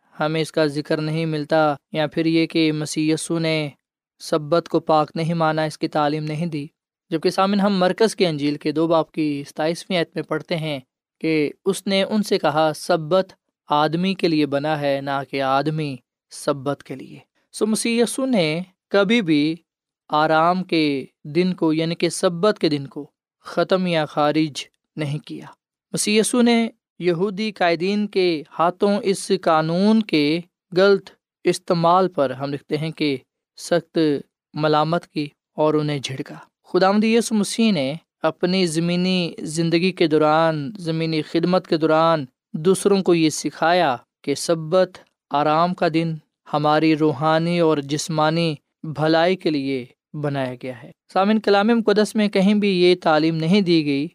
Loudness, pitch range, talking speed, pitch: -20 LUFS, 155-185 Hz, 155 wpm, 165 Hz